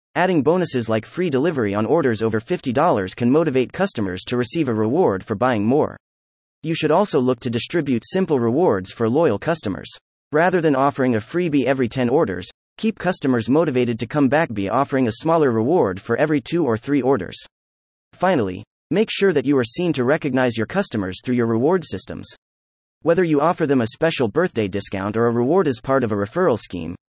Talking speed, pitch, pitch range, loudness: 190 wpm, 130 Hz, 110-160 Hz, -20 LUFS